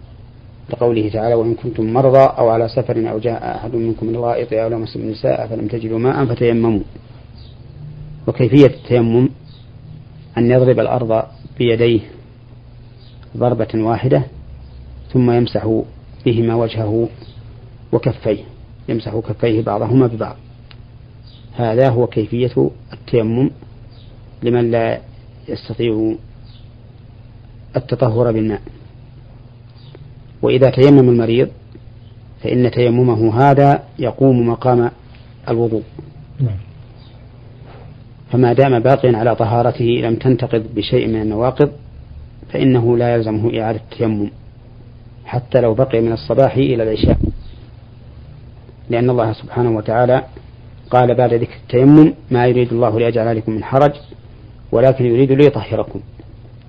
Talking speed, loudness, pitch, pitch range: 100 wpm, -15 LUFS, 120 Hz, 115-125 Hz